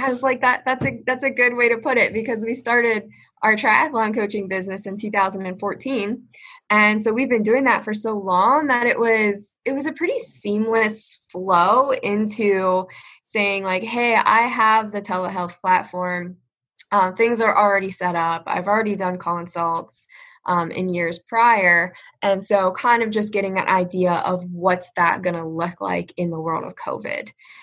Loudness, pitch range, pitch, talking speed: -20 LUFS, 185-235 Hz, 210 Hz, 180 wpm